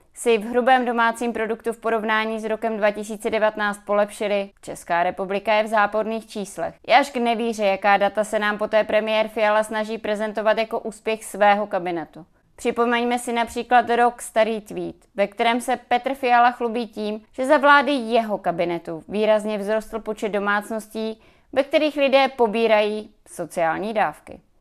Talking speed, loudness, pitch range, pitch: 150 wpm, -21 LUFS, 210-235 Hz, 220 Hz